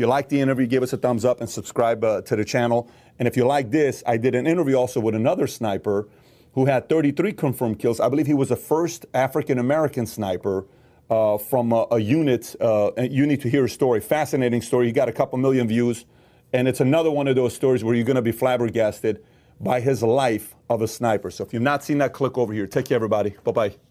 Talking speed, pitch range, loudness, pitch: 240 wpm, 115-135 Hz, -22 LUFS, 125 Hz